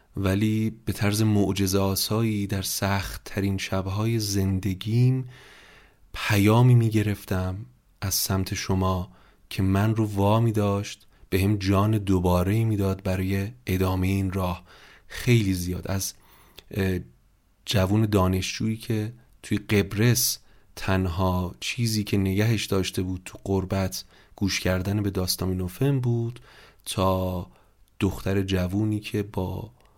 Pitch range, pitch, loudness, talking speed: 95-110 Hz, 100 Hz, -25 LUFS, 115 wpm